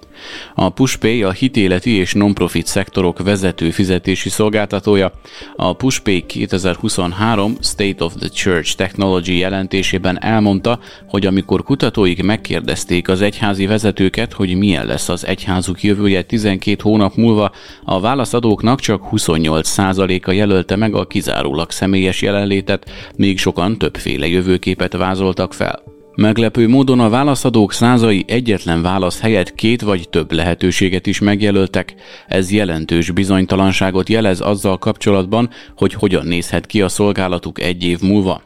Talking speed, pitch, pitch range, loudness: 130 wpm, 95 Hz, 90-105 Hz, -15 LUFS